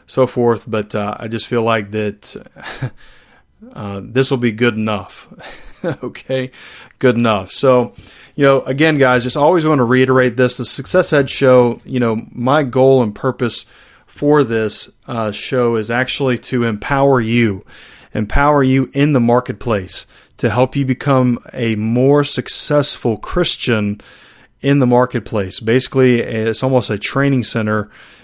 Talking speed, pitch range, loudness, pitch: 150 wpm, 110-130 Hz, -15 LUFS, 125 Hz